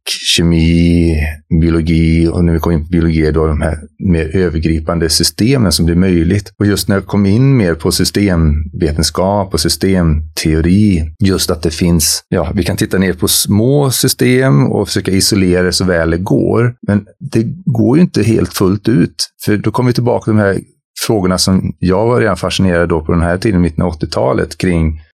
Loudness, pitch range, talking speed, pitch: -12 LUFS, 85-105 Hz, 190 wpm, 90 Hz